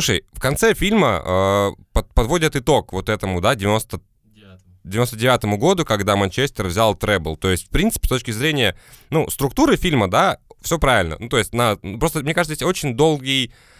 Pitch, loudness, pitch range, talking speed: 115 Hz, -19 LUFS, 100-150 Hz, 185 wpm